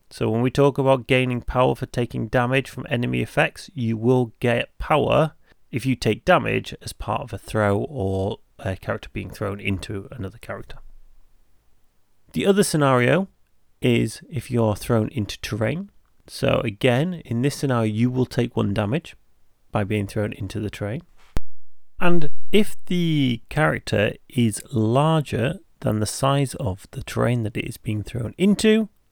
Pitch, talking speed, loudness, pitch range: 120 Hz, 160 wpm, -23 LUFS, 105-140 Hz